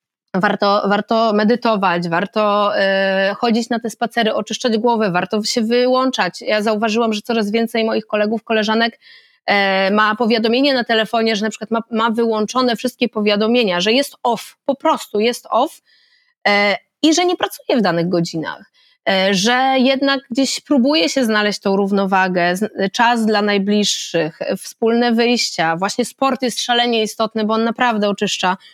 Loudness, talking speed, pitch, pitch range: -17 LUFS, 145 wpm, 225 Hz, 205-240 Hz